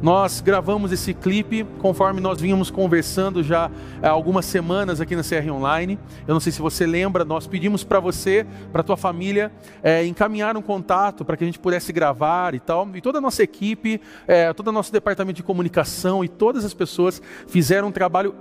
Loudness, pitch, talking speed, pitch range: -21 LUFS, 185 Hz, 200 wpm, 170-200 Hz